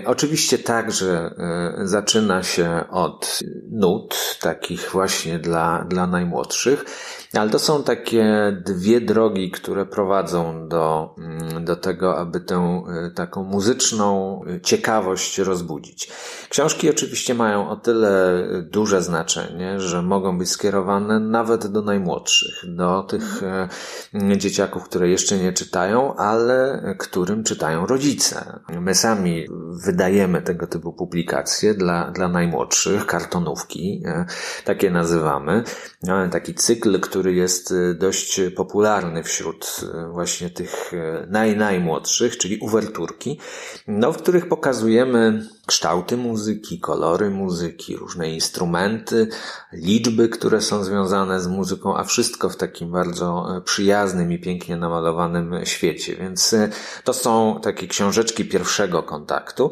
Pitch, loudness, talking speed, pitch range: 95 Hz, -20 LUFS, 115 wpm, 90-110 Hz